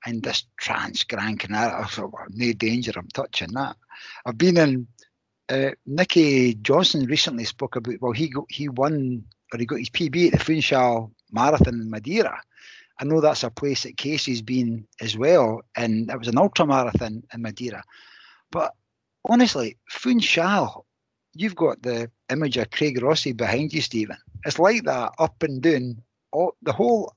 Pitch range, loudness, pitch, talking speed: 115-155 Hz, -23 LUFS, 125 Hz, 170 wpm